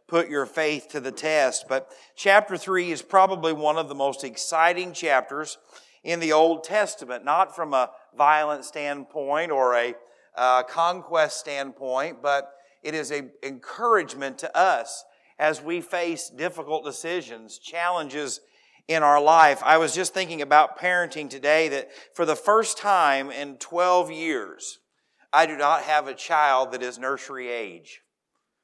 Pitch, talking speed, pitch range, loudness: 155 Hz, 150 wpm, 140-170 Hz, -23 LUFS